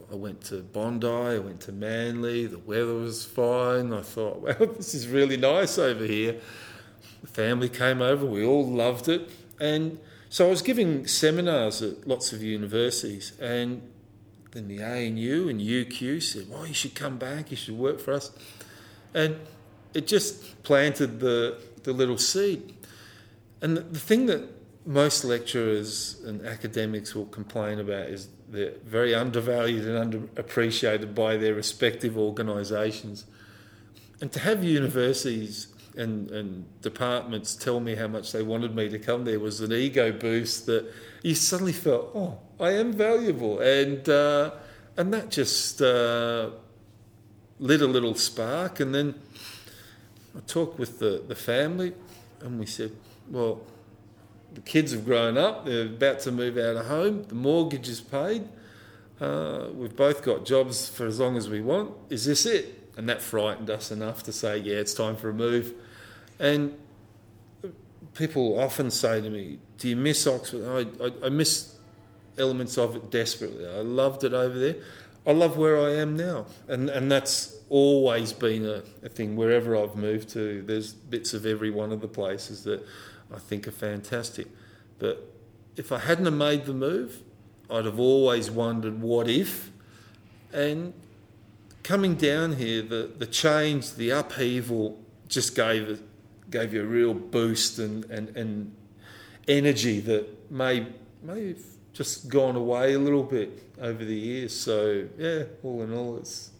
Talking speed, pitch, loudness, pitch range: 160 wpm, 115 Hz, -27 LUFS, 110-140 Hz